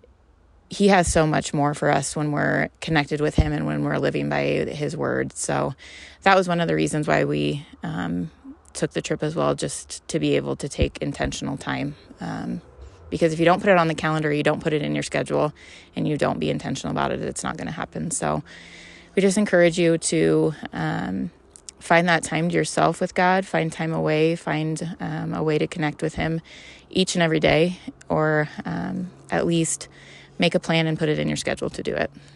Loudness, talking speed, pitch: -23 LUFS, 215 wpm, 155 Hz